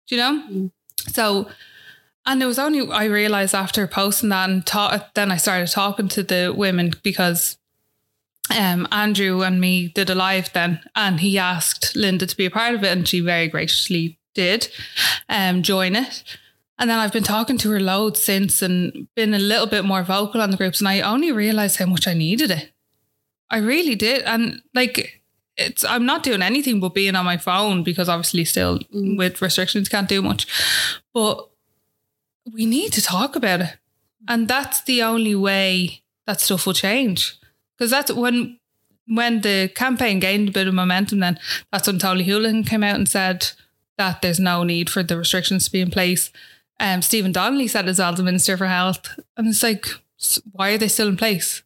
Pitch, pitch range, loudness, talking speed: 195 Hz, 185-220 Hz, -19 LUFS, 195 wpm